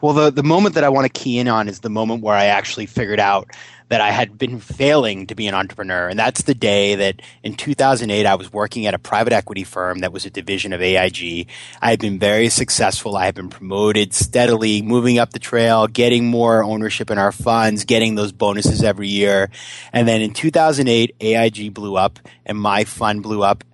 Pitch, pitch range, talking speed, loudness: 110 Hz, 100-120 Hz, 215 wpm, -17 LUFS